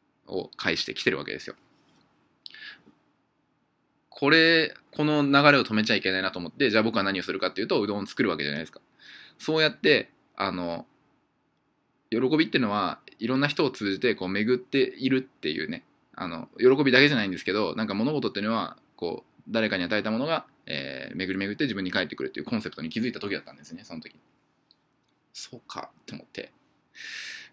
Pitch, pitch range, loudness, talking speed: 125 Hz, 95-145 Hz, -26 LUFS, 395 characters per minute